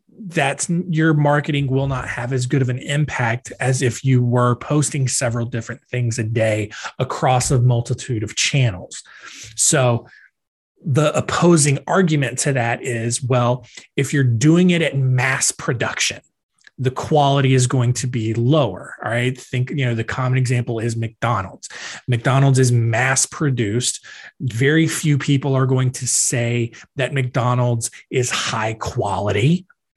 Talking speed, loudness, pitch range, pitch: 150 wpm, -19 LUFS, 120-140 Hz, 125 Hz